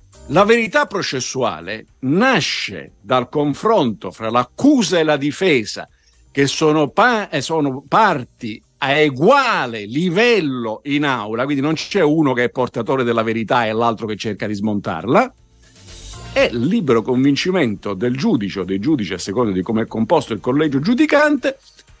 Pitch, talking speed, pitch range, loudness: 130 Hz, 145 wpm, 110-155 Hz, -17 LUFS